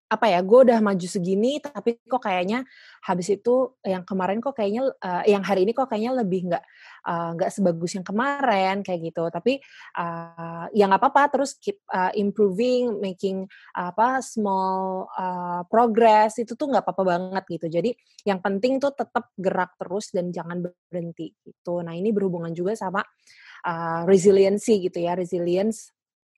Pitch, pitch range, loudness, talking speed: 195 Hz, 180-235 Hz, -23 LUFS, 160 wpm